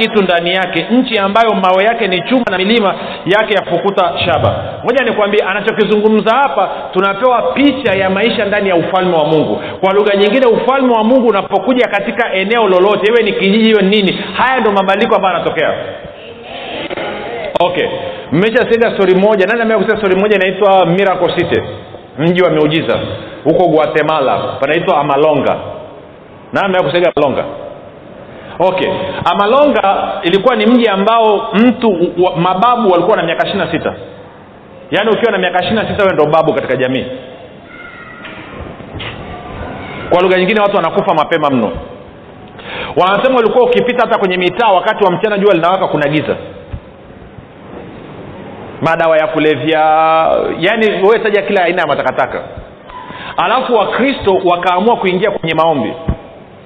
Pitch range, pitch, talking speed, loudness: 180-225 Hz, 200 Hz, 130 wpm, -12 LUFS